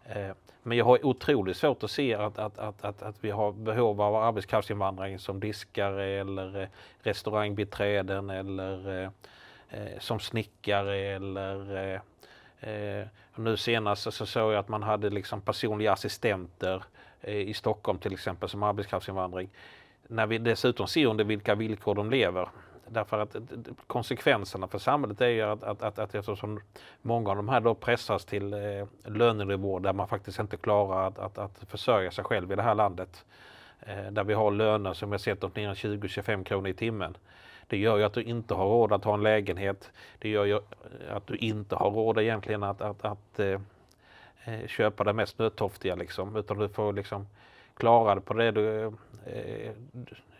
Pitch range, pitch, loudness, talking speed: 100-110 Hz, 105 Hz, -30 LUFS, 170 wpm